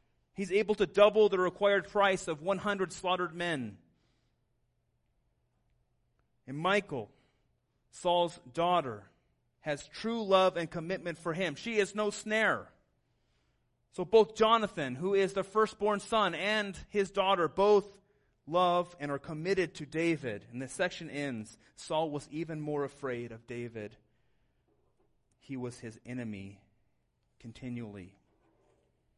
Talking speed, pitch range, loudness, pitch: 125 wpm, 120-195 Hz, -31 LUFS, 170 Hz